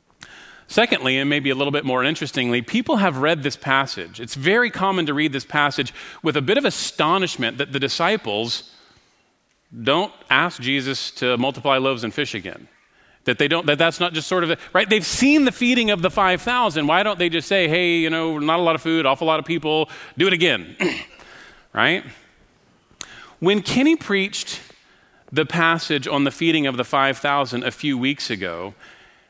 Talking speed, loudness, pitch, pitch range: 185 wpm, -20 LUFS, 155 Hz, 135-180 Hz